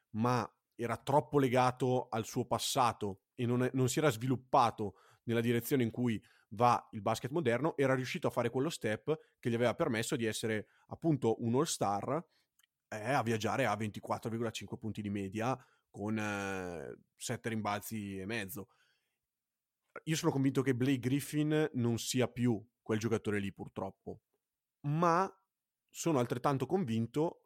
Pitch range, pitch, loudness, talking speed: 110-135 Hz, 120 Hz, -34 LUFS, 150 wpm